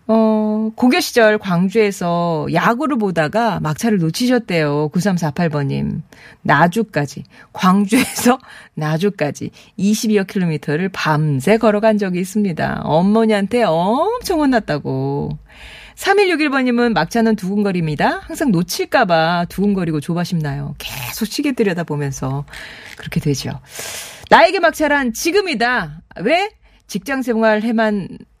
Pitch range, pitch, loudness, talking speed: 165-230 Hz, 205 Hz, -17 LUFS, 265 characters per minute